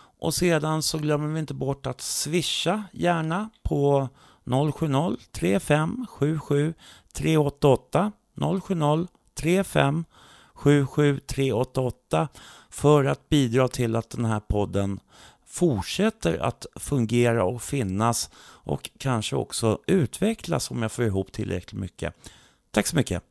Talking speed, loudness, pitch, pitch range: 115 wpm, -25 LUFS, 140 Hz, 120-160 Hz